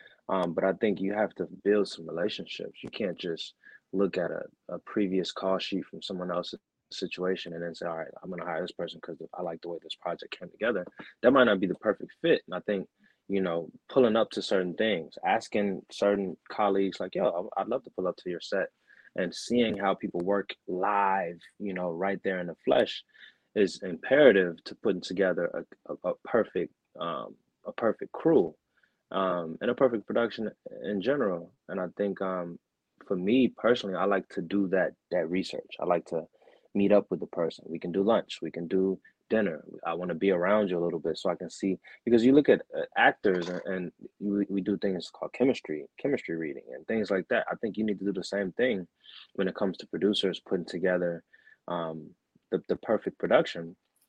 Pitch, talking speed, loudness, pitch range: 95 Hz, 210 wpm, -29 LUFS, 90-100 Hz